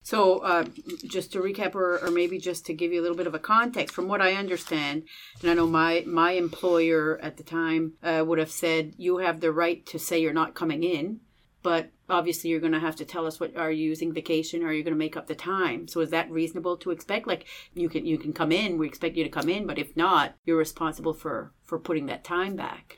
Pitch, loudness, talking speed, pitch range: 165 Hz, -27 LUFS, 255 wpm, 160-180 Hz